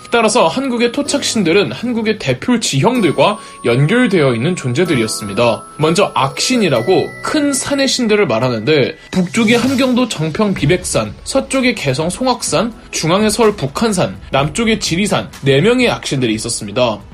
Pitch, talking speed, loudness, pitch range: 210 Hz, 335 characters per minute, -14 LUFS, 145-245 Hz